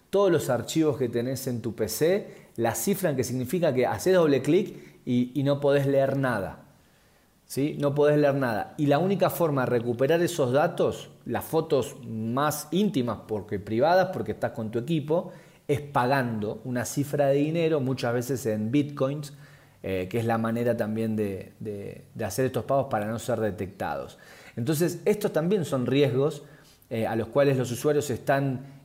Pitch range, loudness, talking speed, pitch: 115-150 Hz, -26 LUFS, 175 wpm, 135 Hz